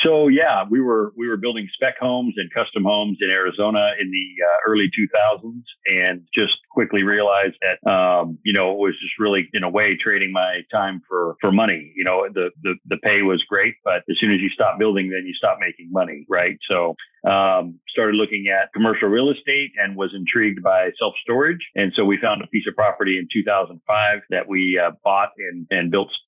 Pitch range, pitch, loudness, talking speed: 95-105 Hz, 100 Hz, -19 LUFS, 210 wpm